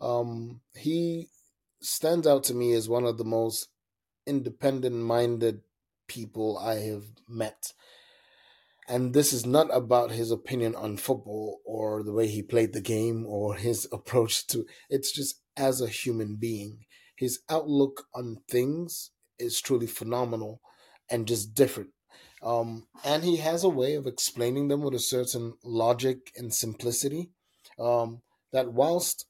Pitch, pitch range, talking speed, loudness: 120 Hz, 115-135 Hz, 145 wpm, -28 LUFS